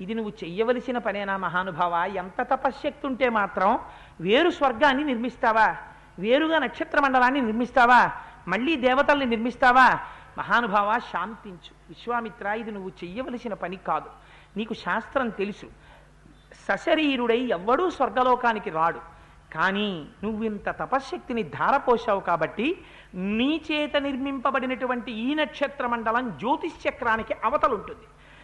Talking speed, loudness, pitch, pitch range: 105 wpm, -24 LUFS, 240 Hz, 200-275 Hz